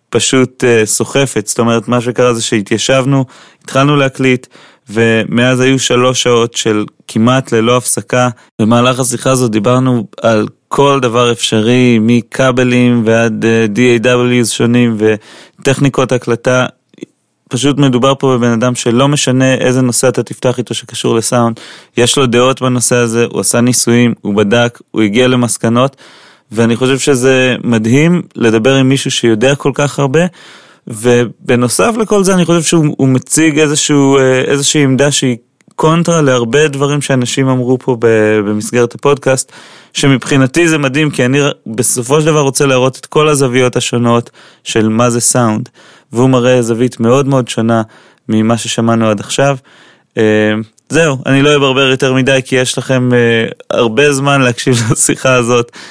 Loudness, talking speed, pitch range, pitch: -10 LUFS, 140 wpm, 120-135 Hz, 125 Hz